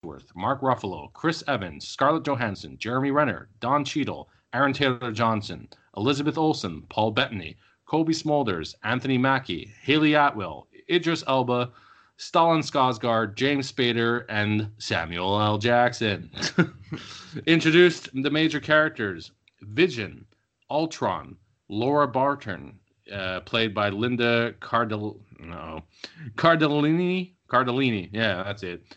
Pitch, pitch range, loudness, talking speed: 120 Hz, 105-145 Hz, -24 LUFS, 105 wpm